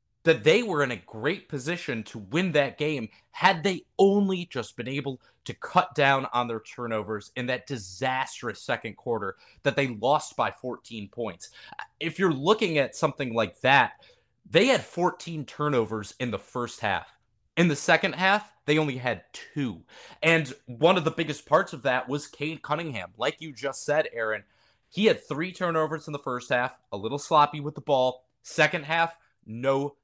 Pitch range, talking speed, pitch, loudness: 125-165 Hz, 180 wpm, 145 Hz, -26 LUFS